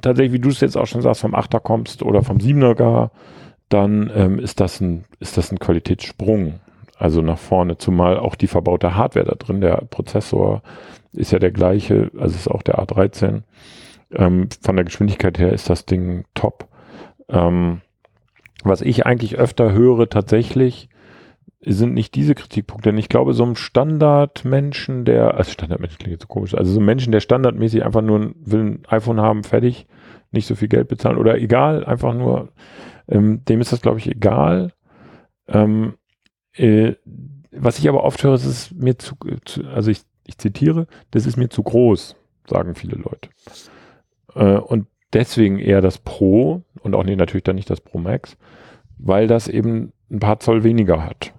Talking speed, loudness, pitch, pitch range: 180 wpm, -17 LUFS, 110 Hz, 95-120 Hz